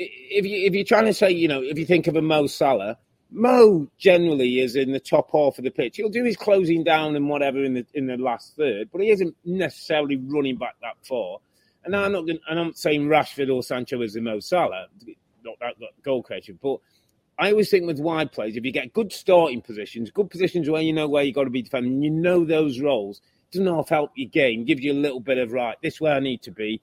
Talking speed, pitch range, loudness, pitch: 255 wpm, 135-185 Hz, -22 LUFS, 155 Hz